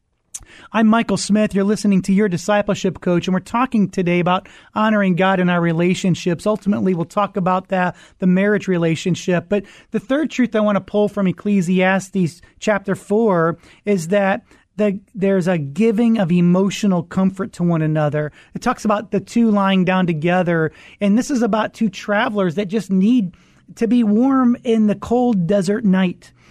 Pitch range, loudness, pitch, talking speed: 180-215 Hz, -18 LUFS, 195 Hz, 170 wpm